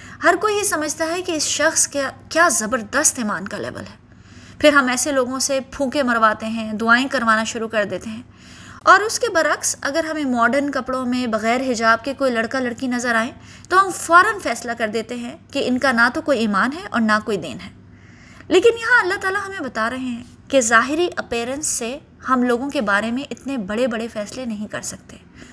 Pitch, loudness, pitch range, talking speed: 255 Hz, -19 LUFS, 225-300 Hz, 210 wpm